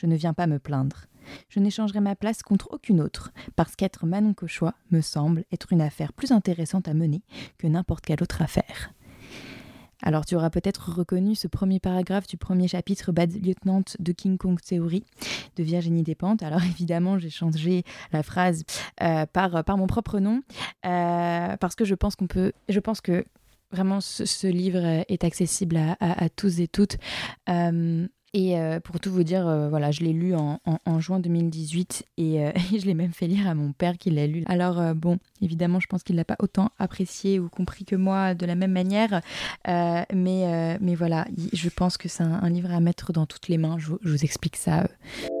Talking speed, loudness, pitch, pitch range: 210 wpm, -26 LUFS, 175 Hz, 165-190 Hz